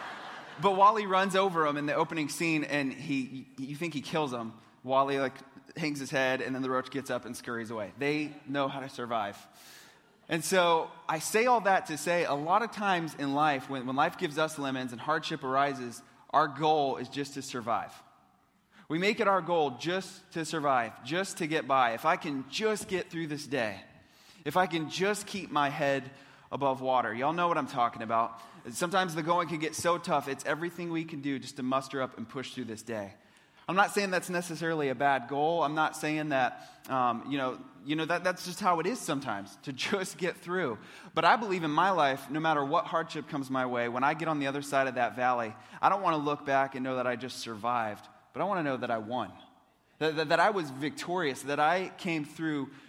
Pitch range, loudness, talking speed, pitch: 130-170 Hz, -30 LUFS, 230 wpm, 150 Hz